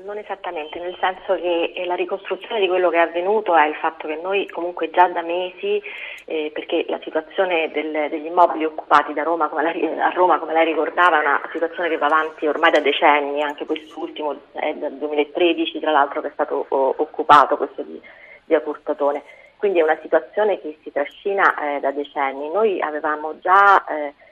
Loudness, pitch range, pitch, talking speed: -20 LUFS, 150-180 Hz, 160 Hz, 185 wpm